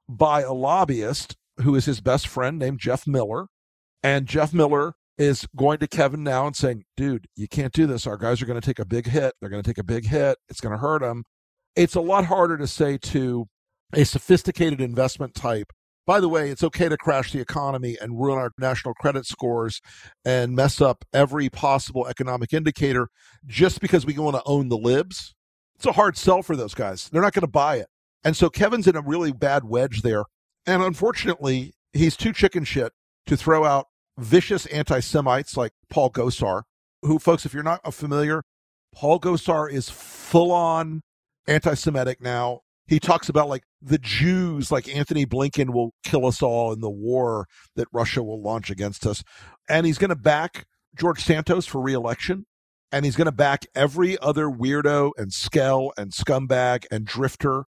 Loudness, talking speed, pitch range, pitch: -23 LUFS, 190 wpm, 120-155 Hz, 140 Hz